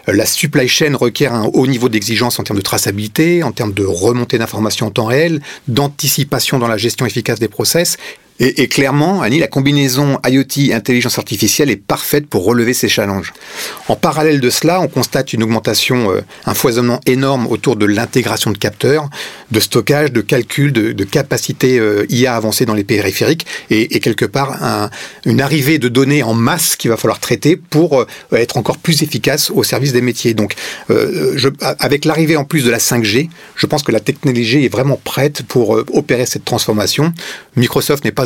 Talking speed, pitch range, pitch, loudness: 195 wpm, 115-145 Hz, 125 Hz, -13 LUFS